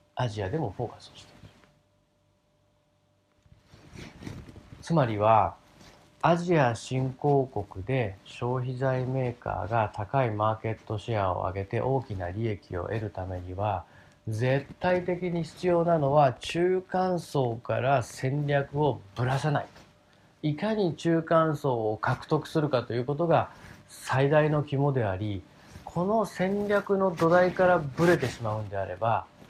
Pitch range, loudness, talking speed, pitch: 110-160 Hz, -28 LUFS, 260 characters per minute, 130 Hz